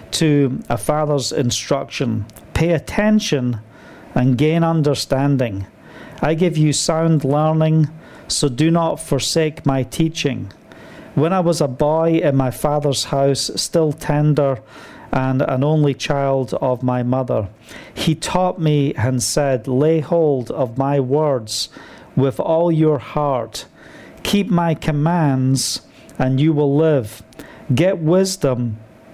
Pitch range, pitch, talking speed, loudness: 130-160 Hz, 145 Hz, 125 wpm, -18 LUFS